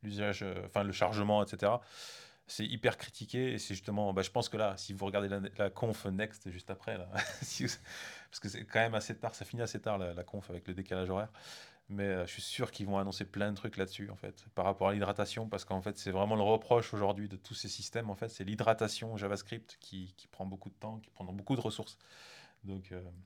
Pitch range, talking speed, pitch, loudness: 95-110 Hz, 240 wpm, 100 Hz, -37 LUFS